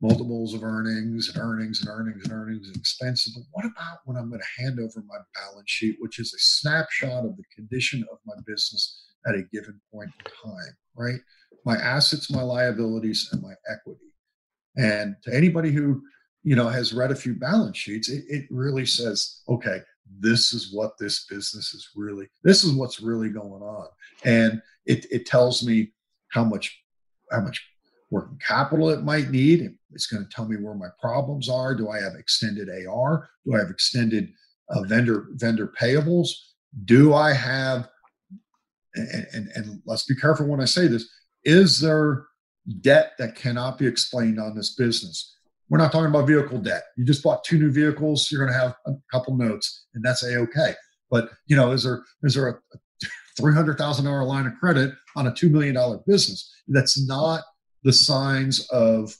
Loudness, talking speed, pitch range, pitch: -23 LUFS, 190 wpm, 115-150 Hz, 125 Hz